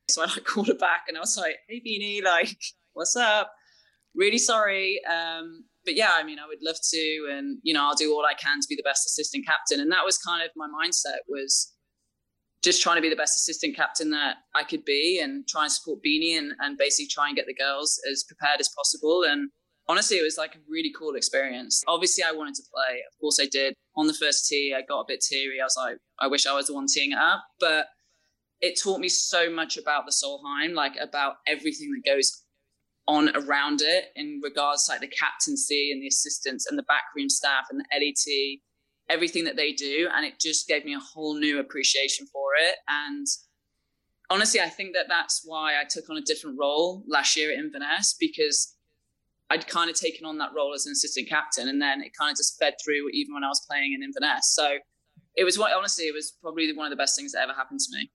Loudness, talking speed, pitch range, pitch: -25 LUFS, 235 wpm, 145-210 Hz, 155 Hz